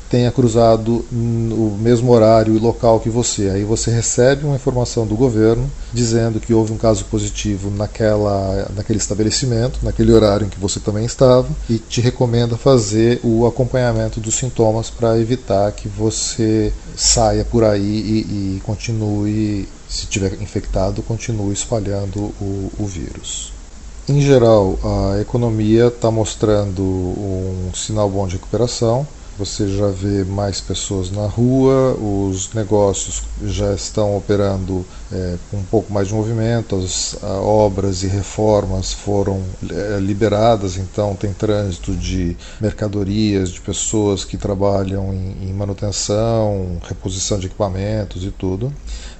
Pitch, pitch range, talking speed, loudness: 105 Hz, 95-115 Hz, 135 wpm, -17 LUFS